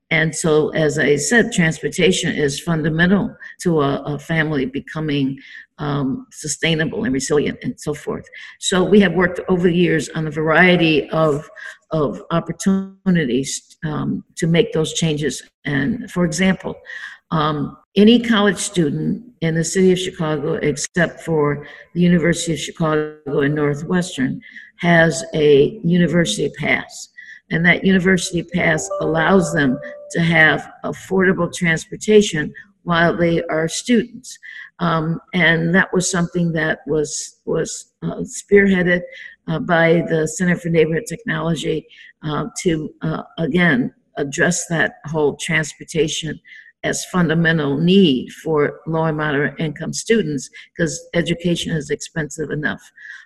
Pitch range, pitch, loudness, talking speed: 155-185 Hz, 165 Hz, -18 LUFS, 130 wpm